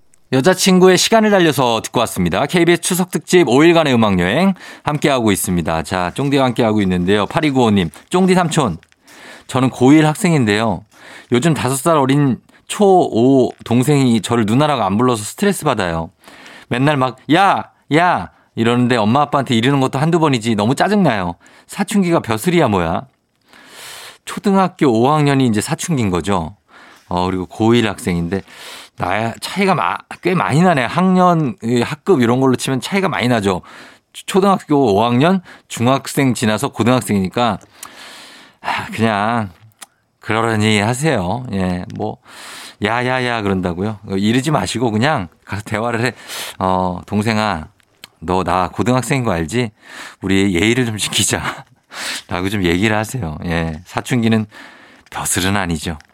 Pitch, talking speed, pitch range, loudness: 120 Hz, 305 characters per minute, 100-150 Hz, -16 LUFS